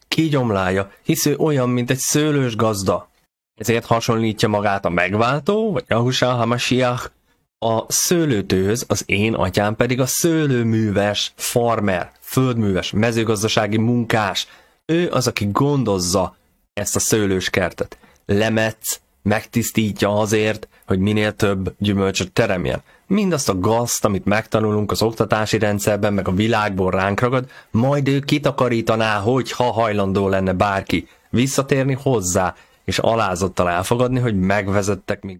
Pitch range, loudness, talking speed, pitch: 100-125 Hz, -19 LUFS, 125 wpm, 110 Hz